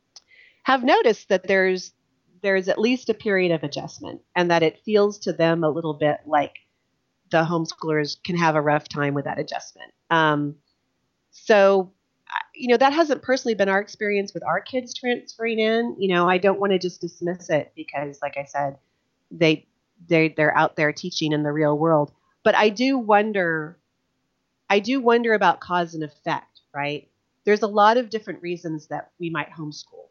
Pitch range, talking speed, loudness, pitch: 155-215 Hz, 180 wpm, -22 LUFS, 180 Hz